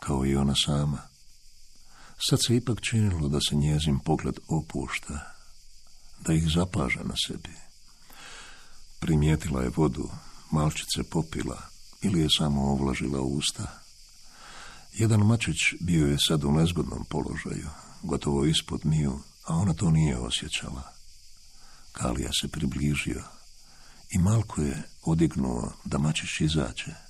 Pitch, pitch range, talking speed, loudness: 75 Hz, 70-80 Hz, 120 wpm, -27 LUFS